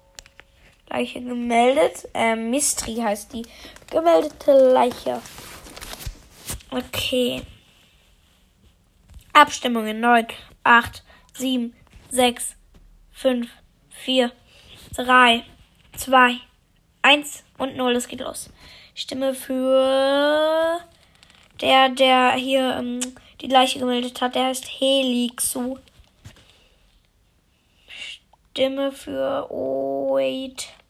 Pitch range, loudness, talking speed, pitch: 245-270 Hz, -20 LUFS, 80 wpm, 255 Hz